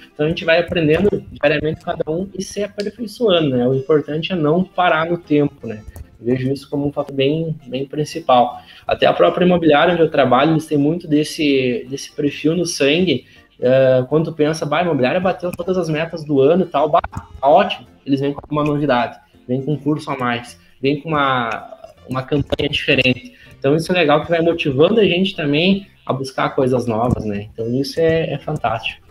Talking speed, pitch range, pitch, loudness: 200 wpm, 135-165 Hz, 150 Hz, -17 LUFS